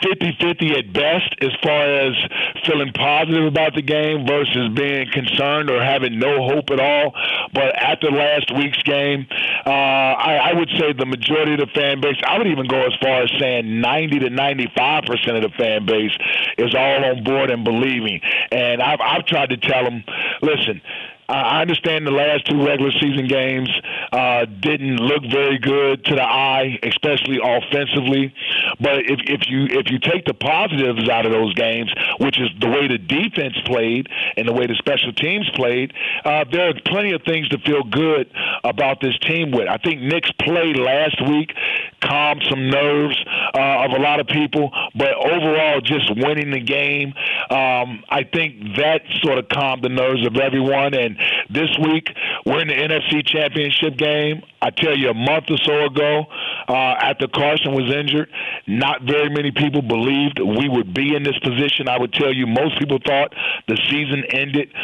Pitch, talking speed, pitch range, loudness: 140 Hz, 185 wpm, 130-150 Hz, -17 LUFS